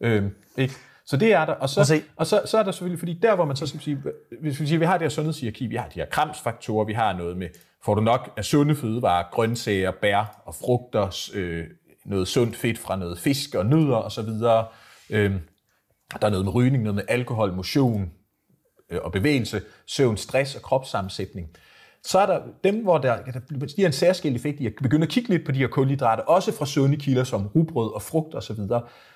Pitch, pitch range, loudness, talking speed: 125 Hz, 105-150 Hz, -24 LUFS, 220 wpm